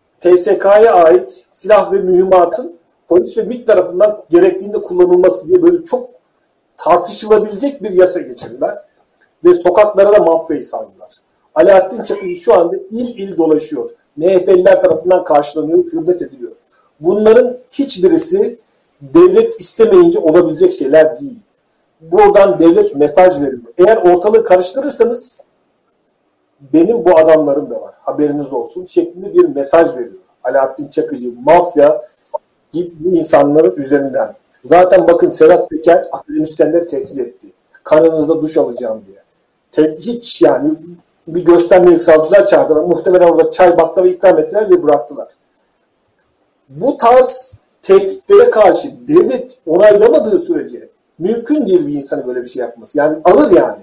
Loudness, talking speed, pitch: -11 LUFS, 125 wpm, 210 Hz